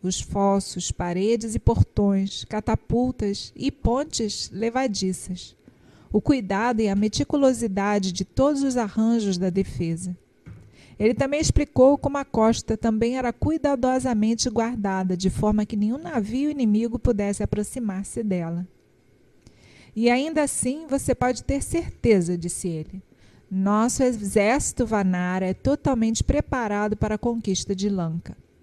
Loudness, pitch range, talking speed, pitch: -24 LUFS, 195-250 Hz, 125 wpm, 220 Hz